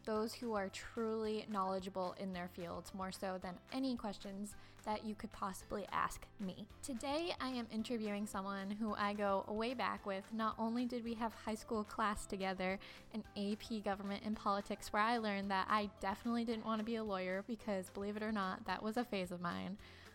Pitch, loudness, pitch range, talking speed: 210 Hz, -42 LUFS, 195-225 Hz, 200 wpm